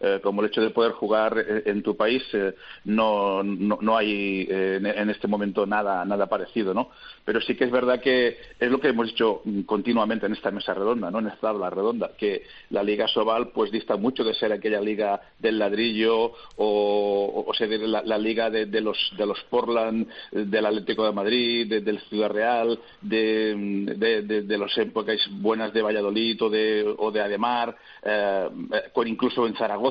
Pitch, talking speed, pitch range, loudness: 110 Hz, 190 wpm, 105-115 Hz, -25 LUFS